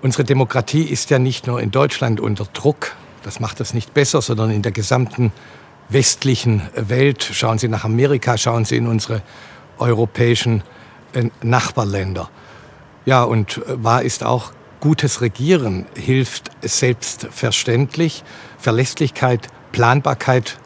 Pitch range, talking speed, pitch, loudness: 110-135 Hz, 120 wpm, 120 Hz, -18 LUFS